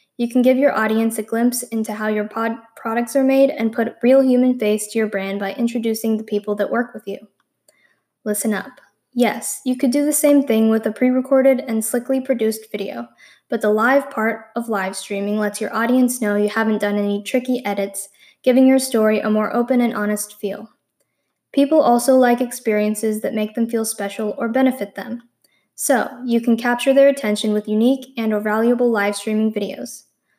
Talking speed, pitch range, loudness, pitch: 195 wpm, 210-250 Hz, -19 LUFS, 225 Hz